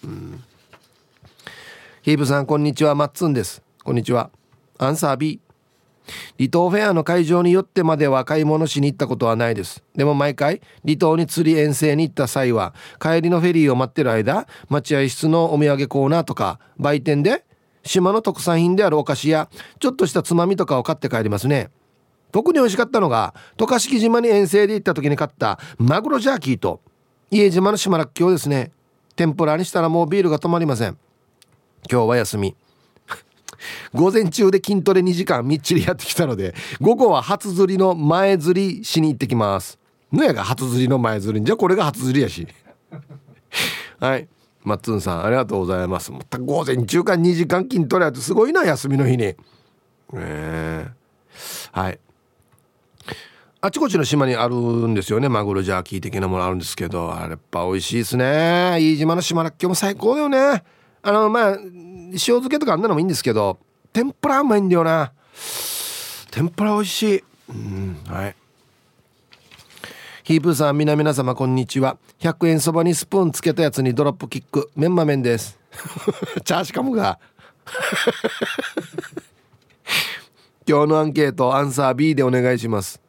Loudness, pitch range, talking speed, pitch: -19 LUFS, 125-180 Hz, 350 characters per minute, 150 Hz